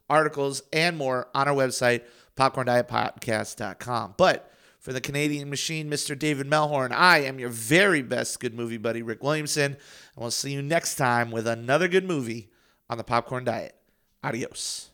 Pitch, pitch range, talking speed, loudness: 130 Hz, 120-145 Hz, 160 wpm, -25 LUFS